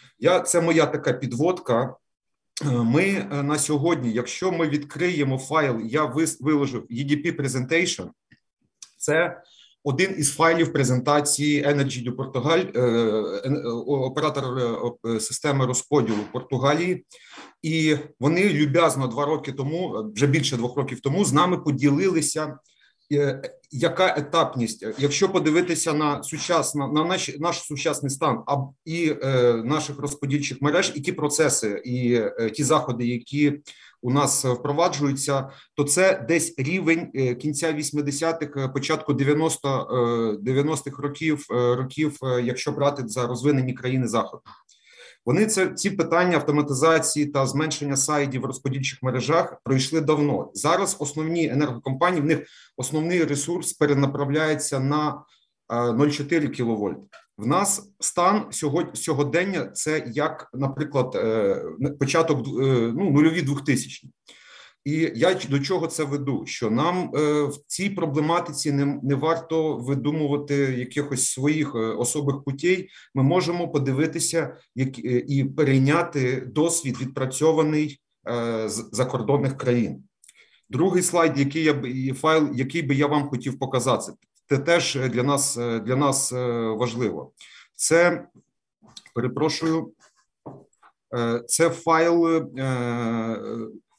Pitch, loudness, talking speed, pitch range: 145 Hz, -23 LUFS, 120 wpm, 130-160 Hz